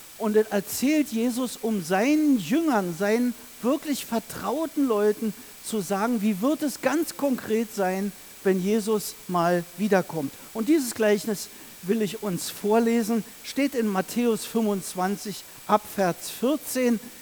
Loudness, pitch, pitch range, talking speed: -25 LUFS, 220 Hz, 200-245 Hz, 125 wpm